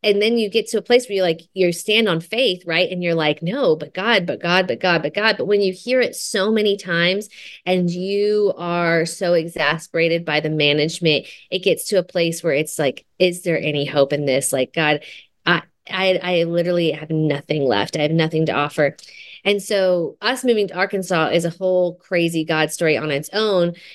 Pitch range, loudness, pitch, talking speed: 160-195 Hz, -19 LUFS, 175 Hz, 215 wpm